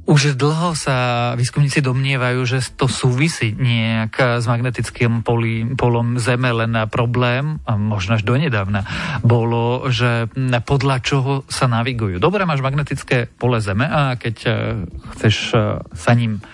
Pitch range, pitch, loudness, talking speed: 115-135 Hz, 125 Hz, -18 LUFS, 130 wpm